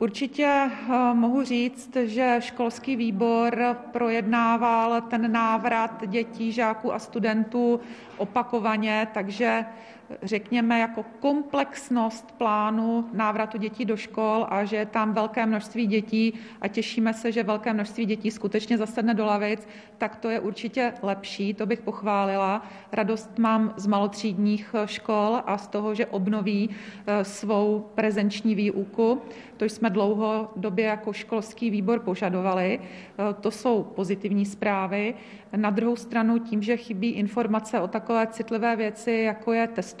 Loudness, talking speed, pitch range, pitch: -26 LUFS, 130 wpm, 210-235 Hz, 220 Hz